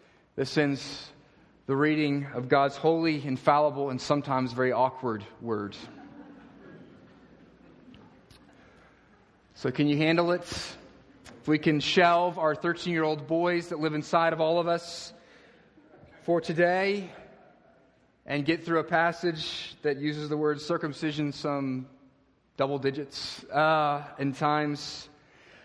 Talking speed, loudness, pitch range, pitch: 115 wpm, -28 LUFS, 140-165 Hz, 150 Hz